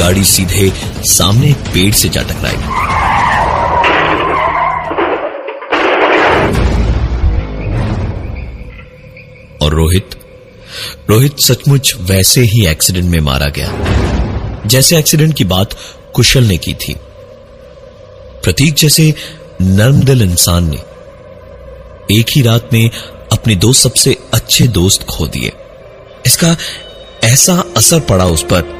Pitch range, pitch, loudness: 90-135 Hz, 105 Hz, -10 LUFS